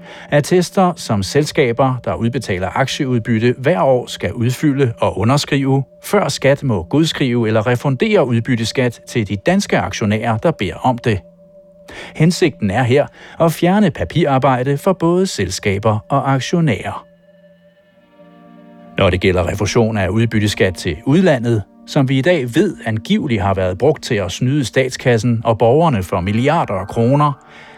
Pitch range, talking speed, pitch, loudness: 110-155 Hz, 140 wpm, 130 Hz, -16 LUFS